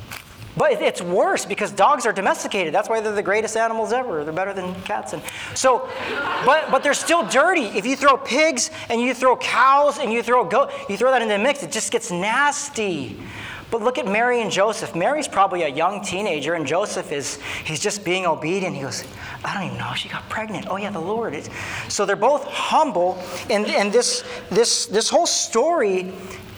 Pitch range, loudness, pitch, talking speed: 190-280 Hz, -20 LUFS, 225 Hz, 205 wpm